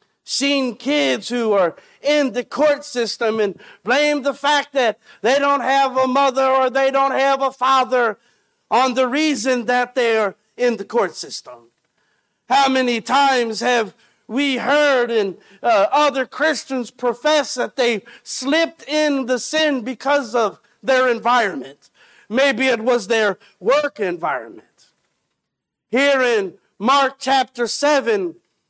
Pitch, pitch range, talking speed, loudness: 260 Hz, 235-280 Hz, 140 wpm, -18 LUFS